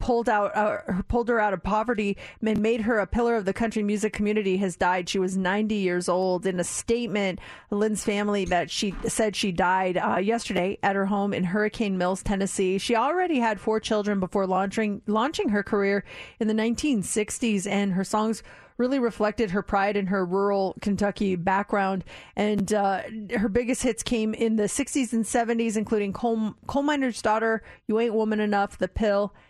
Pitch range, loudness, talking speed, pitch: 195-225 Hz, -25 LUFS, 185 wpm, 210 Hz